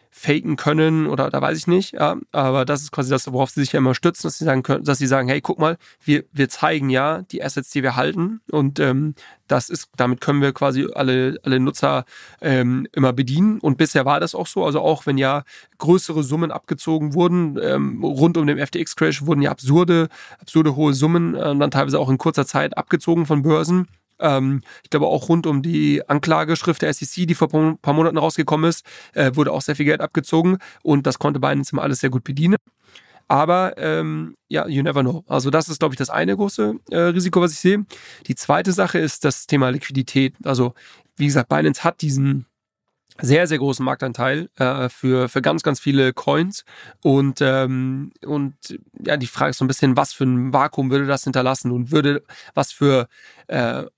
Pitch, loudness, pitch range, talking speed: 145 Hz, -19 LUFS, 135-160 Hz, 200 wpm